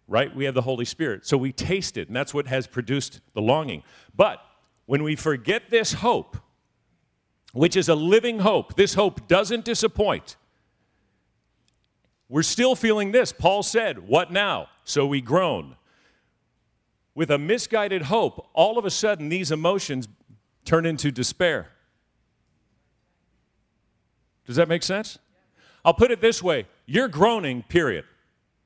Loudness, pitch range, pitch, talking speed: -23 LUFS, 135-205 Hz, 165 Hz, 140 wpm